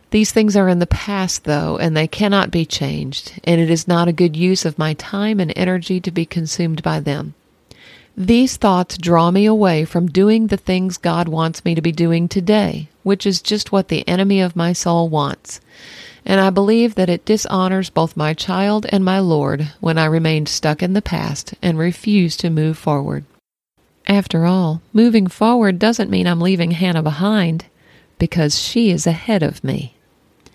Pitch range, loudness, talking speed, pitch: 165-195 Hz, -16 LUFS, 185 wpm, 175 Hz